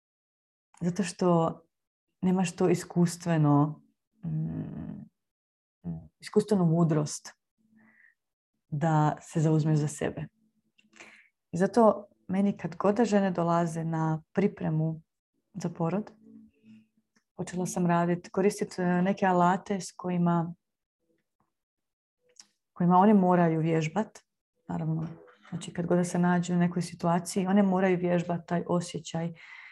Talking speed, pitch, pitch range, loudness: 100 wpm, 175 Hz, 165-200 Hz, -28 LUFS